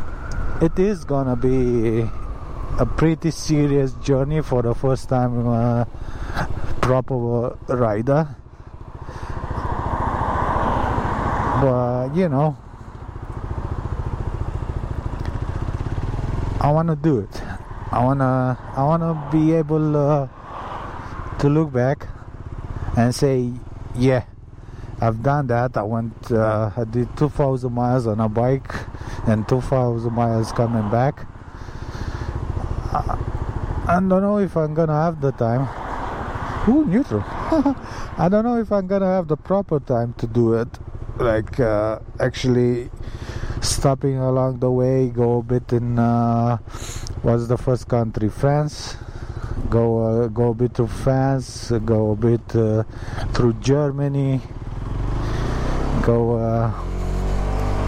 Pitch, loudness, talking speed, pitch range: 120 Hz, -21 LUFS, 115 wpm, 110-130 Hz